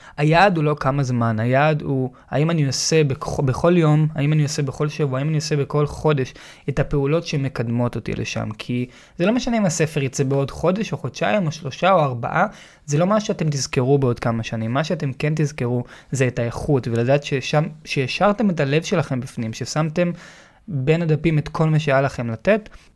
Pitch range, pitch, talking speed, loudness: 130-160 Hz, 145 Hz, 190 wpm, -21 LUFS